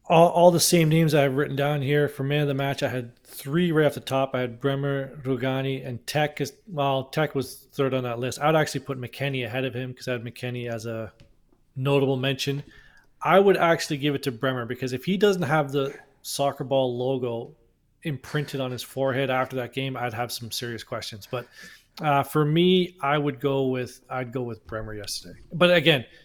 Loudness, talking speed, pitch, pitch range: -25 LUFS, 215 wpm, 135 Hz, 125-145 Hz